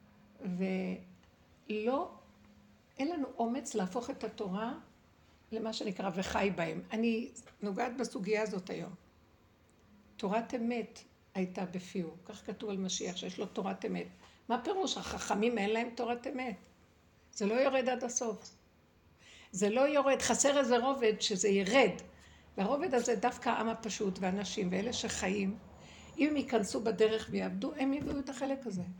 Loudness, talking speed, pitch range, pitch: -34 LUFS, 135 wpm, 185-245 Hz, 220 Hz